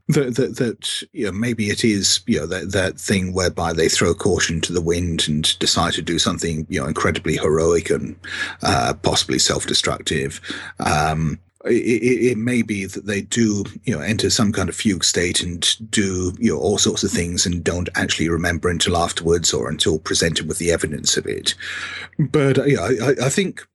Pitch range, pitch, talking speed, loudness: 85-110 Hz, 95 Hz, 195 wpm, -19 LUFS